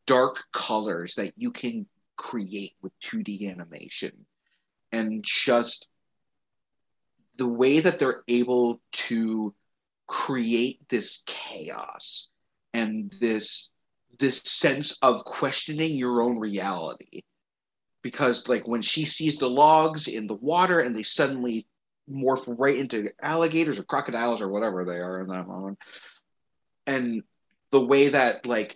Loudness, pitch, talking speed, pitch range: -26 LUFS, 120 Hz, 125 wpm, 110-140 Hz